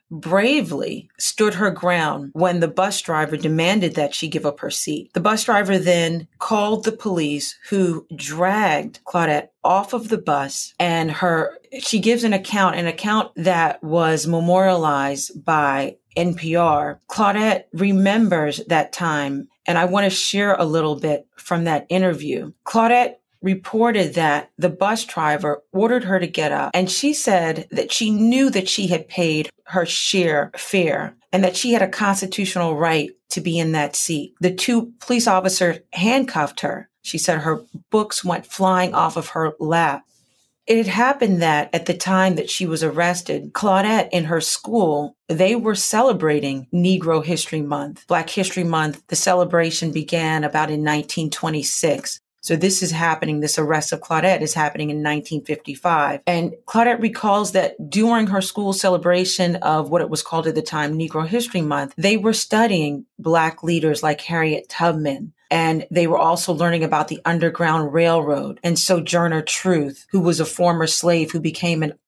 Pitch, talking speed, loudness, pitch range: 175 Hz, 165 wpm, -19 LUFS, 160-195 Hz